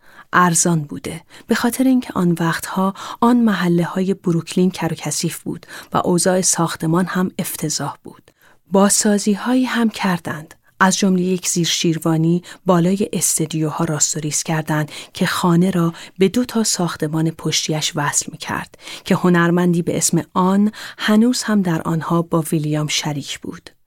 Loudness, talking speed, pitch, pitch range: -18 LUFS, 140 wpm, 175 Hz, 160-190 Hz